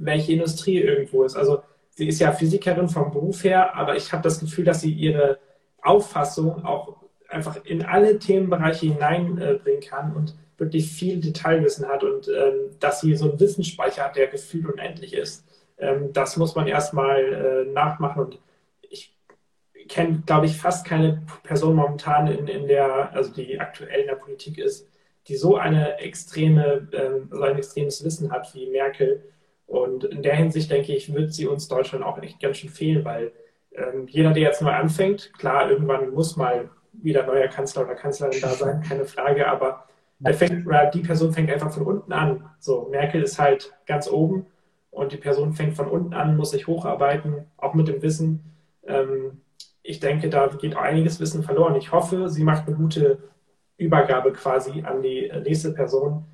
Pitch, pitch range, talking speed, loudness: 155 Hz, 140-180 Hz, 180 wpm, -22 LUFS